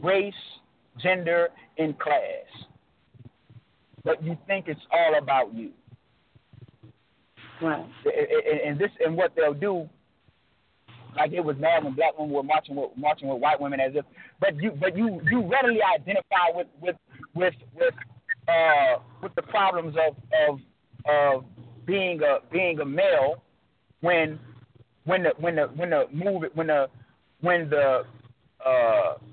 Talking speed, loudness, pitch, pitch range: 140 wpm, -25 LUFS, 170 Hz, 150-210 Hz